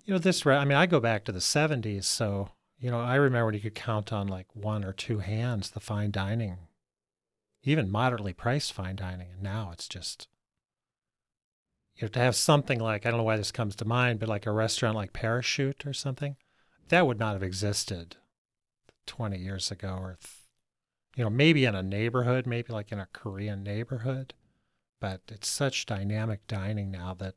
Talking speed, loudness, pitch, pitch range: 195 wpm, -29 LUFS, 110 Hz, 100-125 Hz